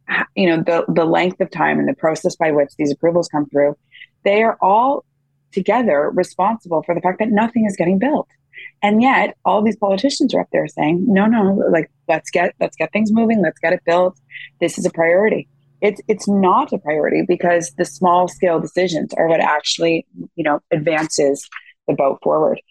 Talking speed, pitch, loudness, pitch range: 195 wpm, 175 Hz, -17 LUFS, 160-205 Hz